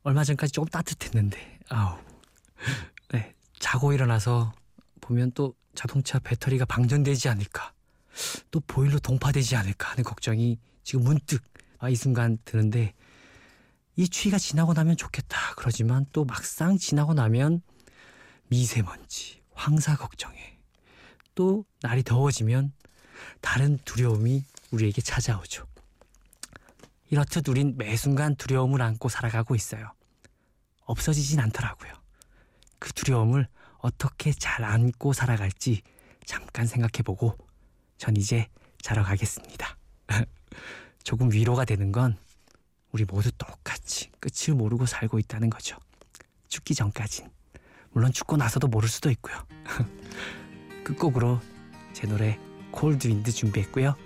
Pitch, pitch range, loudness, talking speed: 120 Hz, 110-140 Hz, -27 LUFS, 270 characters per minute